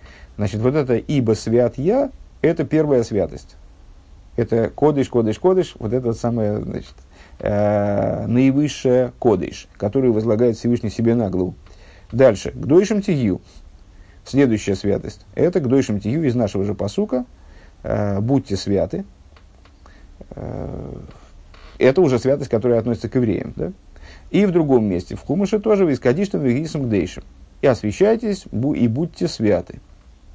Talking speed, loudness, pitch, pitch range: 130 wpm, -19 LUFS, 115 Hz, 95-135 Hz